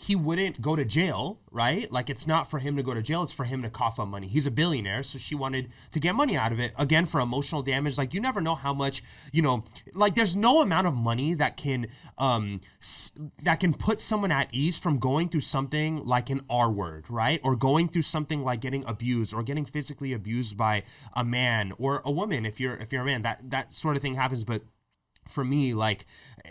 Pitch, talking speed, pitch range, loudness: 135 Hz, 235 wpm, 120-155 Hz, -28 LUFS